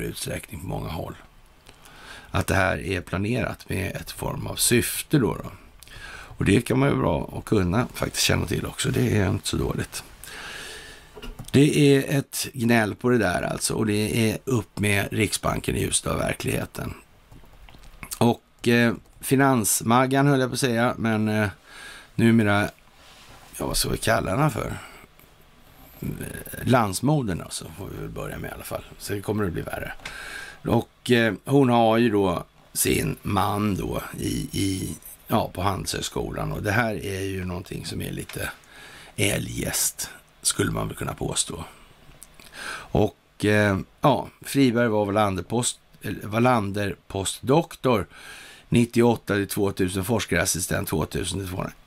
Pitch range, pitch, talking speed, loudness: 100-125 Hz, 110 Hz, 150 wpm, -24 LUFS